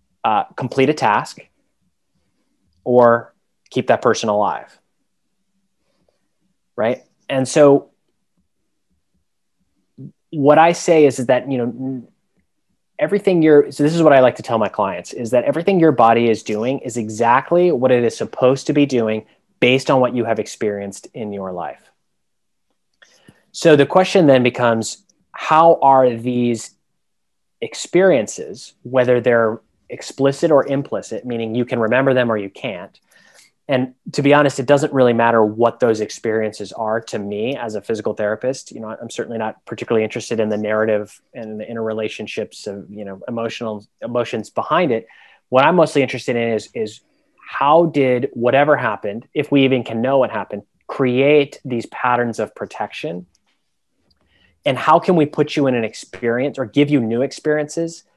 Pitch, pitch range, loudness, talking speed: 125 Hz, 110-140 Hz, -17 LUFS, 160 wpm